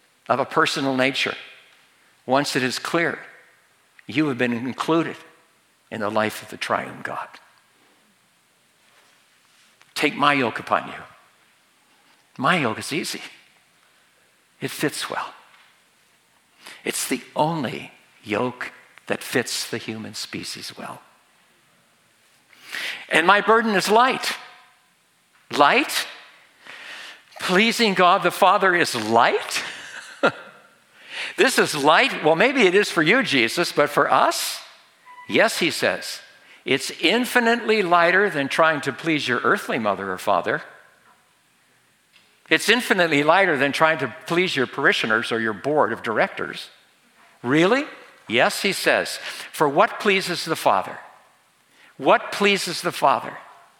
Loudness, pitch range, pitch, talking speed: -20 LUFS, 130-195 Hz, 160 Hz, 120 wpm